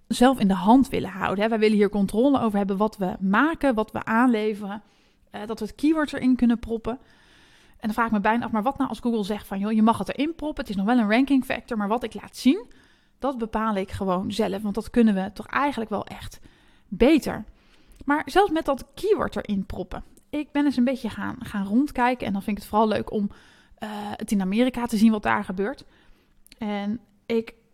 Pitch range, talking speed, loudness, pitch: 205-255 Hz, 225 wpm, -24 LUFS, 225 Hz